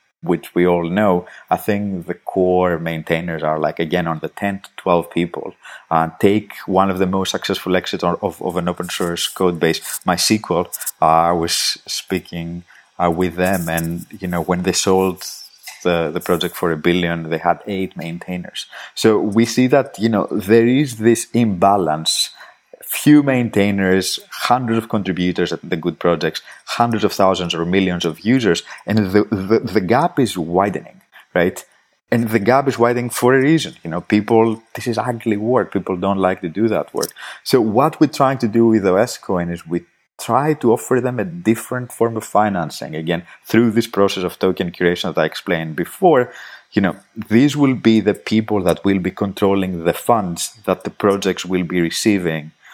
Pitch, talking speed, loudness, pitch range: 95 Hz, 185 wpm, -18 LUFS, 85-115 Hz